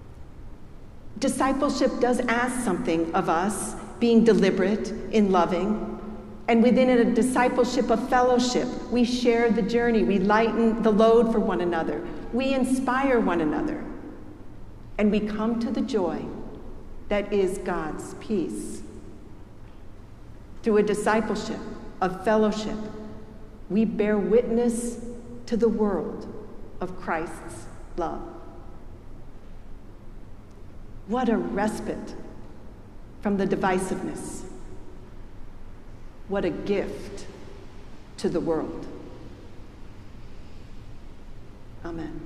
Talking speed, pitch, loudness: 95 wpm, 210 Hz, -24 LUFS